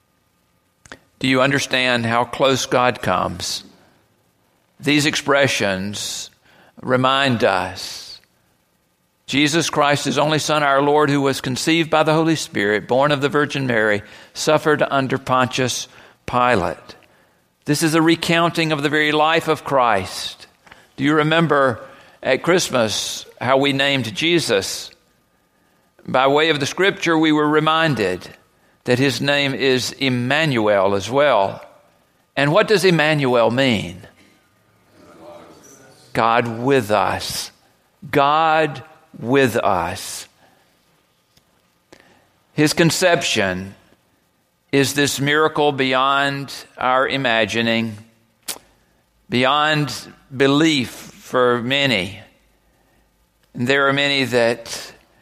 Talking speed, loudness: 105 wpm, -18 LUFS